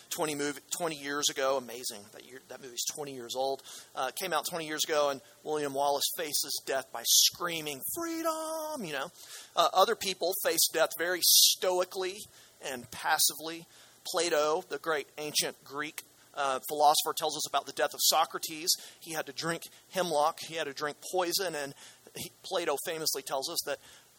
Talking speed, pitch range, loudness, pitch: 170 wpm, 140-175 Hz, -30 LUFS, 155 Hz